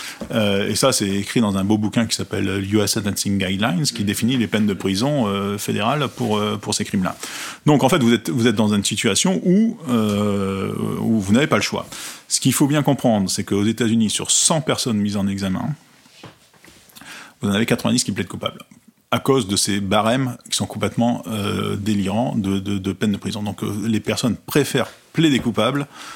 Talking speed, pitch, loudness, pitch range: 200 wpm, 110 Hz, -20 LUFS, 100-125 Hz